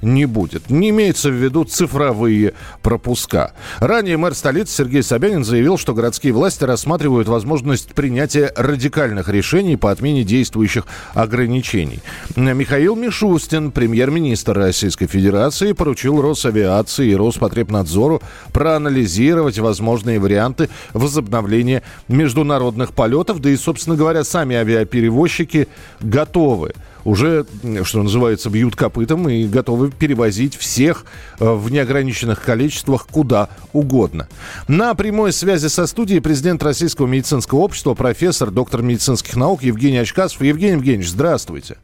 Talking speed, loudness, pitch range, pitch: 115 wpm, -16 LUFS, 115-155 Hz, 130 Hz